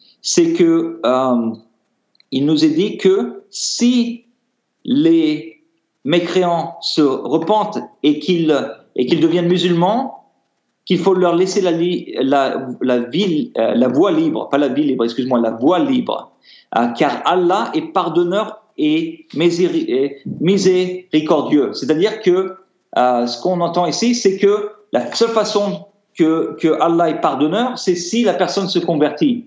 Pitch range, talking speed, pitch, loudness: 155-220 Hz, 140 wpm, 180 Hz, -16 LUFS